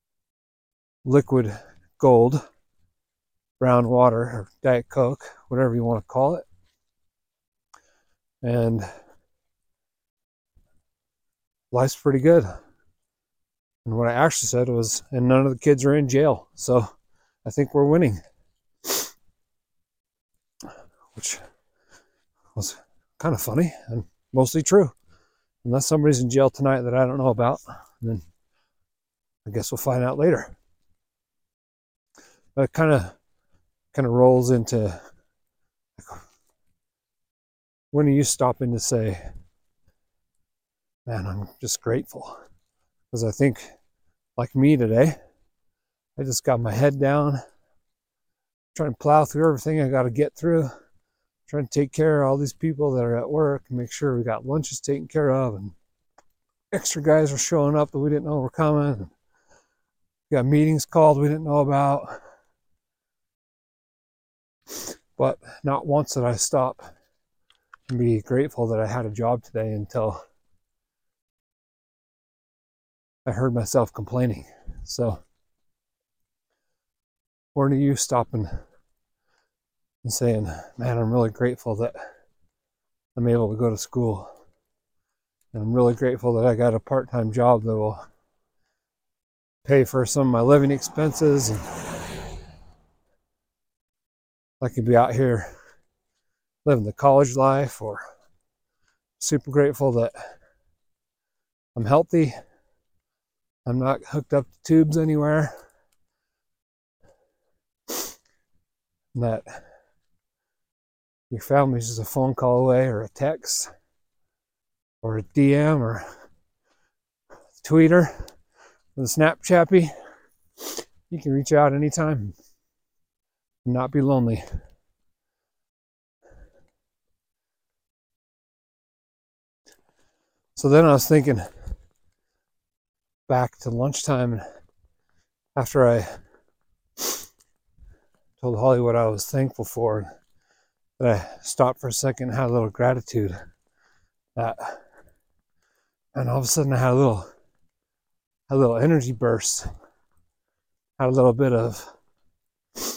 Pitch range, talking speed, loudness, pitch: 95-140 Hz, 115 wpm, -22 LUFS, 120 Hz